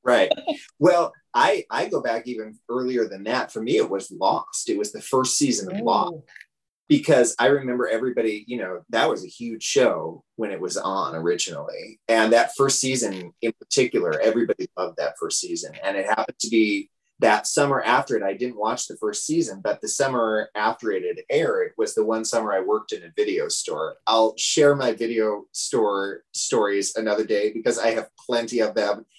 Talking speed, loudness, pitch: 195 wpm, -23 LUFS, 140 Hz